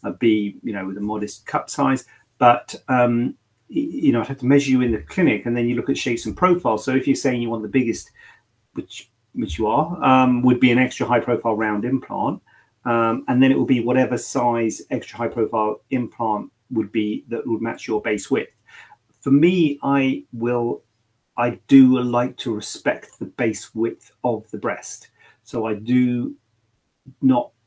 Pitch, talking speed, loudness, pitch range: 120 Hz, 190 wpm, -21 LUFS, 115-130 Hz